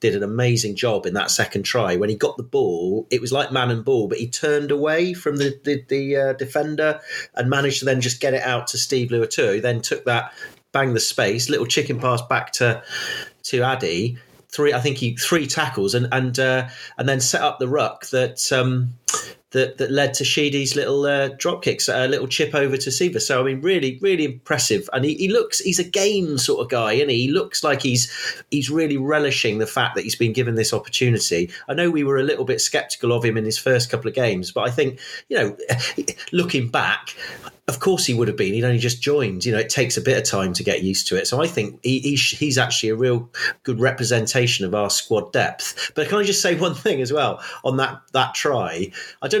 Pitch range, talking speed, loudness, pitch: 120-150 Hz, 235 wpm, -20 LUFS, 135 Hz